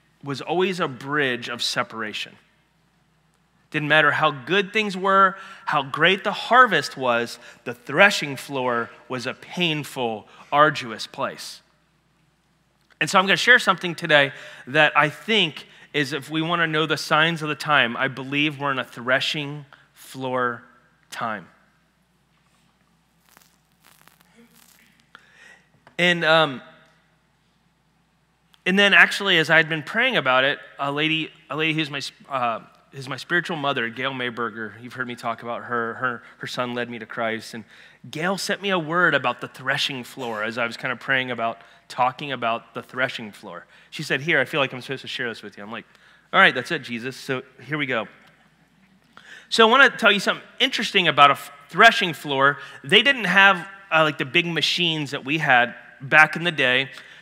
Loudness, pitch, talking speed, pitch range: -20 LUFS, 155 Hz, 175 wpm, 130-175 Hz